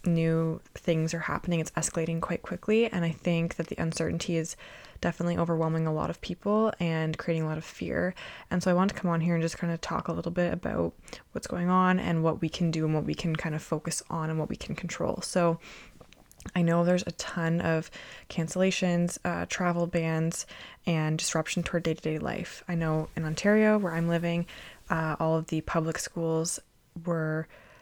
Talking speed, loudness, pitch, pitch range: 210 wpm, -29 LUFS, 165 Hz, 160-175 Hz